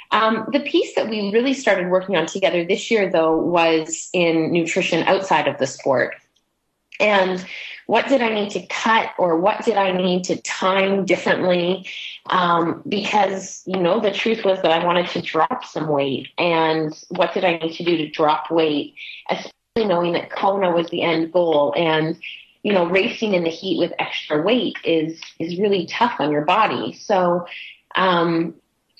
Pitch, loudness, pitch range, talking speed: 180 Hz, -20 LUFS, 165-195 Hz, 180 wpm